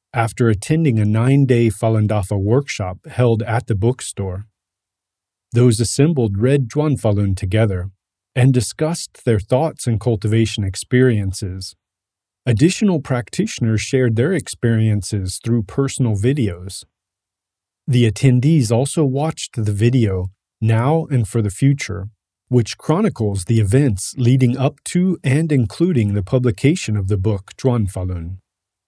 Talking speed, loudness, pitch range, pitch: 125 wpm, -18 LUFS, 100-130 Hz, 115 Hz